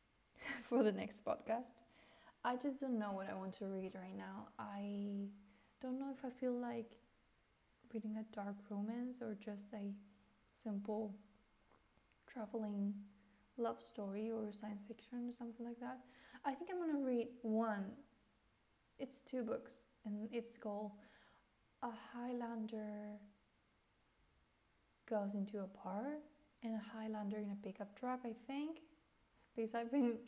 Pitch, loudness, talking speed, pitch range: 220 Hz, -46 LUFS, 140 wpm, 205-245 Hz